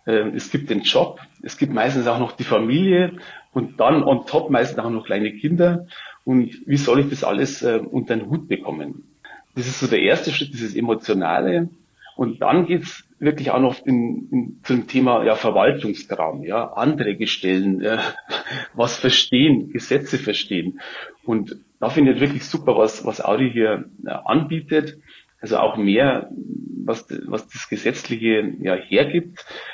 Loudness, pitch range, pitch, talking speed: -20 LUFS, 115-160 Hz, 130 Hz, 160 wpm